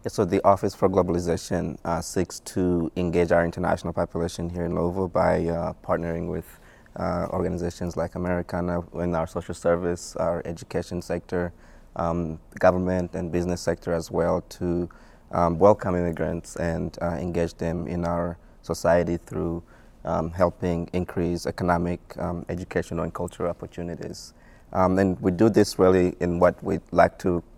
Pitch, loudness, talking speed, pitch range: 85 Hz, -25 LUFS, 150 wpm, 85-90 Hz